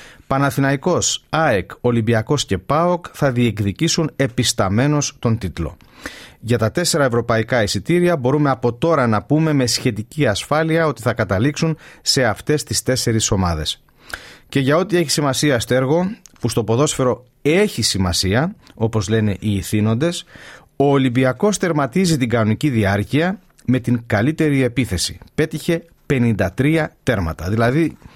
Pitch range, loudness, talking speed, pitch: 115-150 Hz, -18 LUFS, 130 wpm, 130 Hz